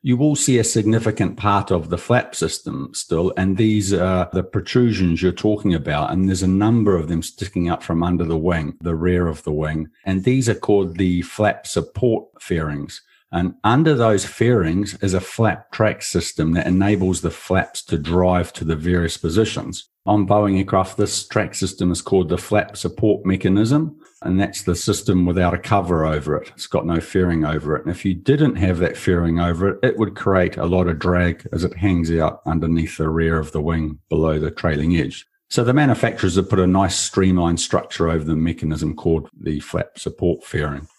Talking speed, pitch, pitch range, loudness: 200 wpm, 90 Hz, 85-100 Hz, -19 LUFS